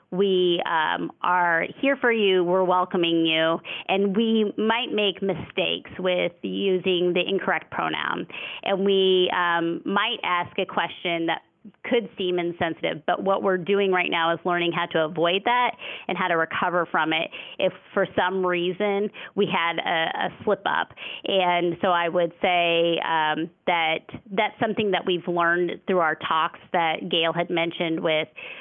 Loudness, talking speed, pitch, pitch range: -23 LUFS, 165 wpm, 180 Hz, 170-195 Hz